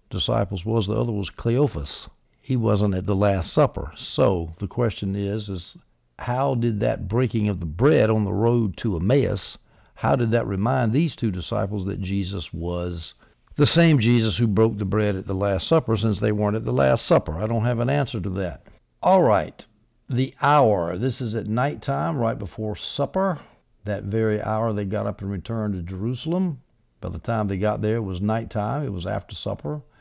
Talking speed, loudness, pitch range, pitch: 195 wpm, -23 LUFS, 100-120 Hz, 105 Hz